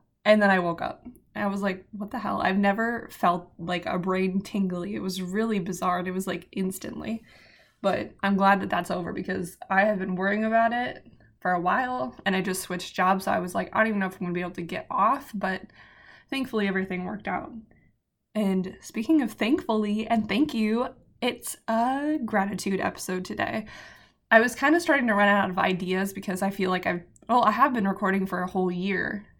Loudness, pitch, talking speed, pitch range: -26 LUFS, 195 Hz, 215 wpm, 185-220 Hz